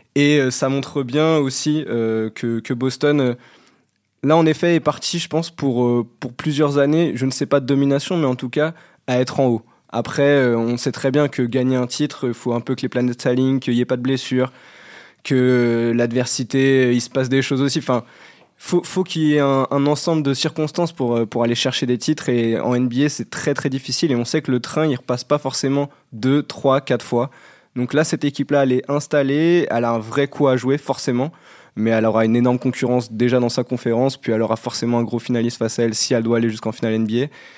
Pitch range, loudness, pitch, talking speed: 120-145 Hz, -19 LUFS, 130 Hz, 245 wpm